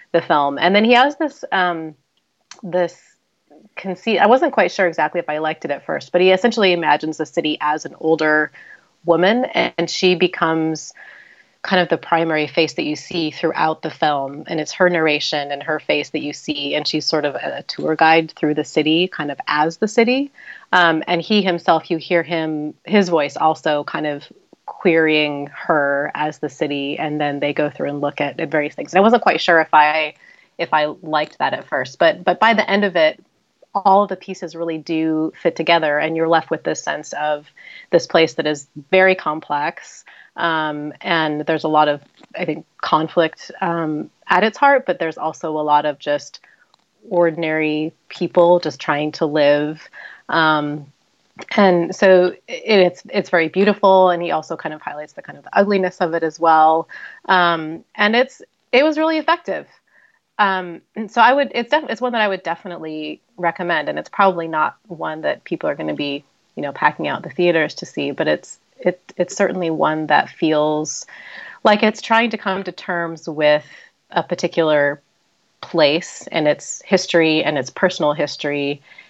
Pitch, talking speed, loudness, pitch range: 165 Hz, 190 wpm, -18 LUFS, 150-185 Hz